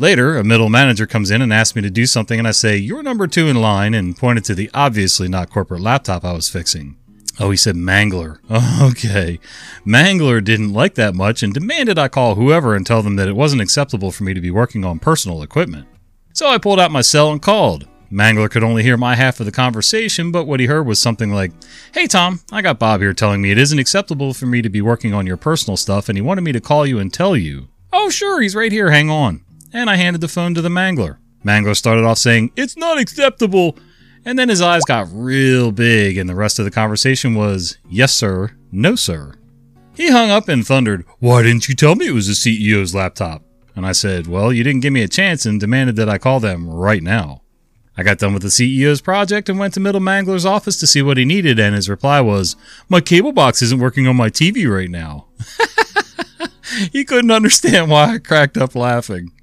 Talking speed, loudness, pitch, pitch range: 230 wpm, -14 LUFS, 120 Hz, 100-155 Hz